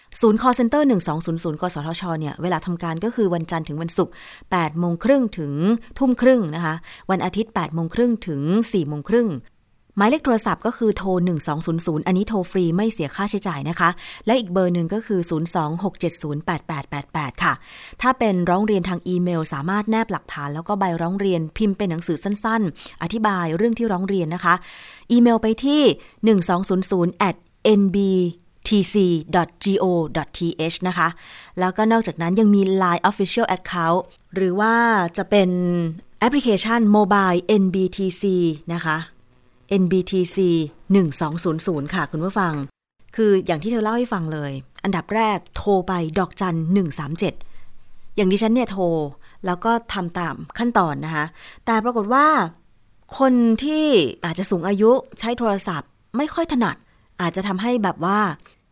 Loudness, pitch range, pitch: -21 LUFS, 170-215 Hz, 185 Hz